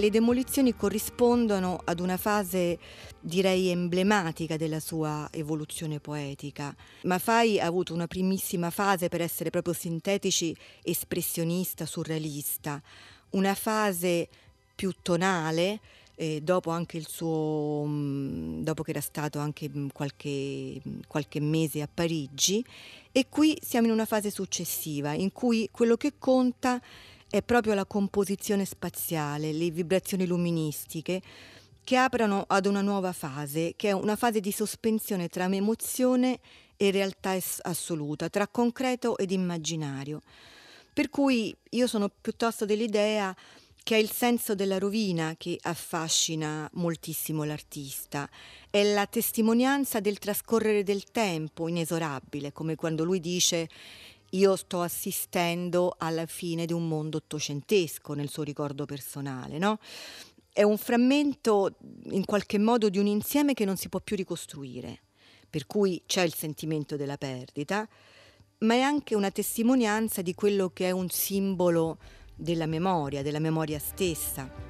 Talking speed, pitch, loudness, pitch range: 130 wpm, 180 Hz, -29 LUFS, 155-205 Hz